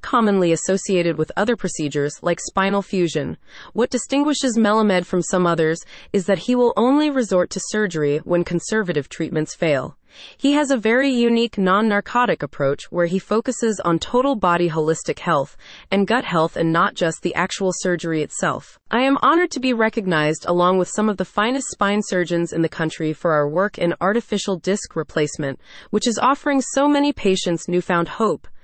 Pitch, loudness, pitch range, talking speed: 190 Hz, -20 LUFS, 170-235 Hz, 175 wpm